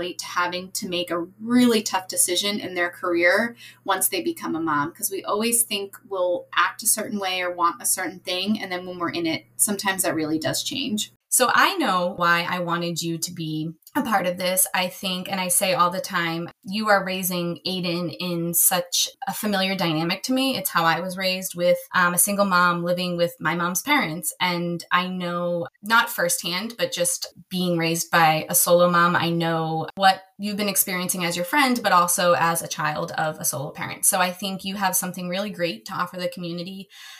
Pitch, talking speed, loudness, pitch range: 180 Hz, 210 wpm, -22 LUFS, 175-200 Hz